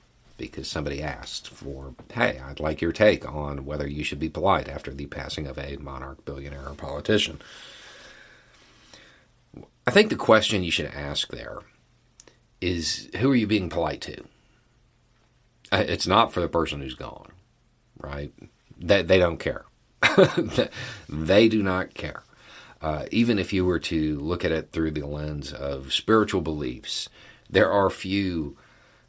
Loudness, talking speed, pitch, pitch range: -25 LUFS, 150 wpm, 75 Hz, 70-95 Hz